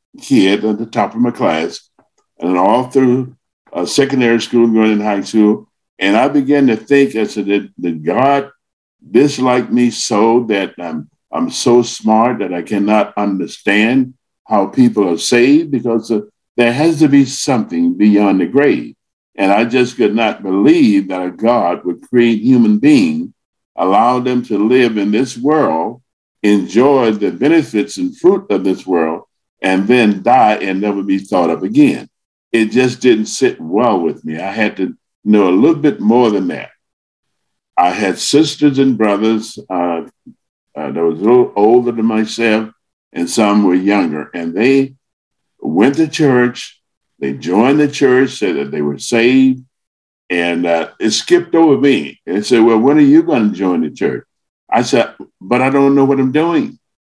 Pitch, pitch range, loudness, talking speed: 115 Hz, 100-135 Hz, -13 LUFS, 170 wpm